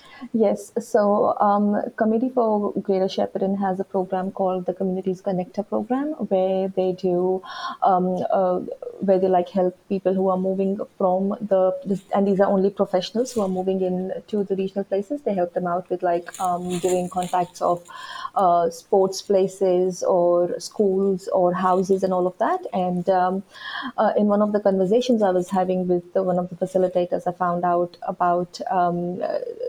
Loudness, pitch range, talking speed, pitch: -22 LUFS, 180-200 Hz, 175 wpm, 190 Hz